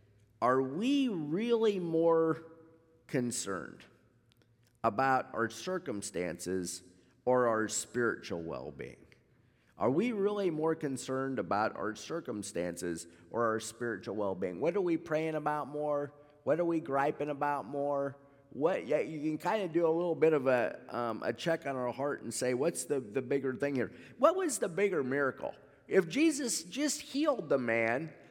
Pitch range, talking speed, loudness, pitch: 115-165 Hz, 155 wpm, -33 LUFS, 140 Hz